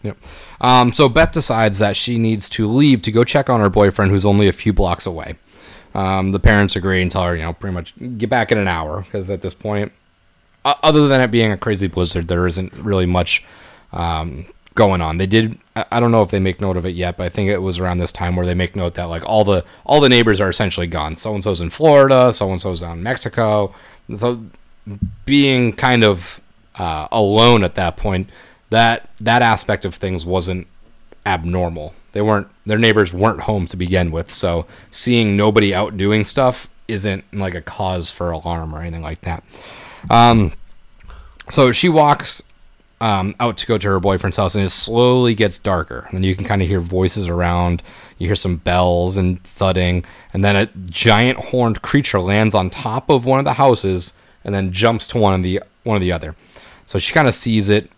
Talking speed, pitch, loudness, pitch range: 205 wpm, 100 Hz, -16 LUFS, 90-110 Hz